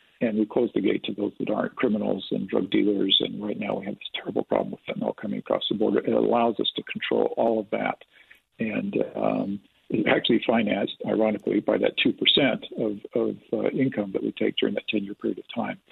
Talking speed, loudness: 220 wpm, -25 LUFS